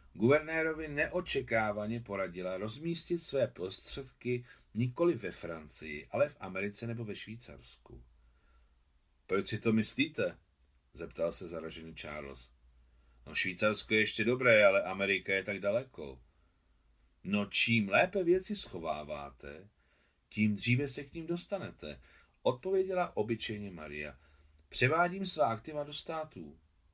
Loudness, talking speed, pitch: -33 LUFS, 115 wpm, 105 Hz